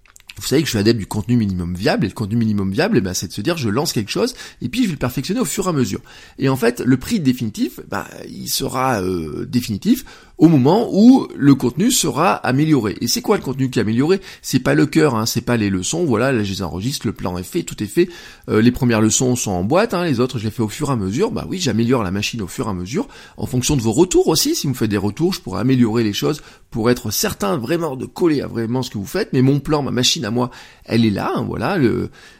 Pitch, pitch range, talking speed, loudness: 125 Hz, 110-150 Hz, 280 wpm, -18 LUFS